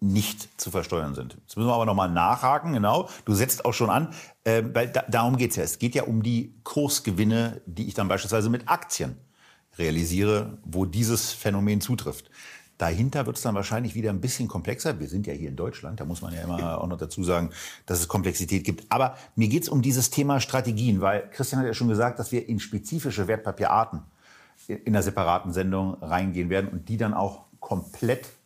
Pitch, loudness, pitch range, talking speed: 105 Hz, -26 LUFS, 95-120 Hz, 205 wpm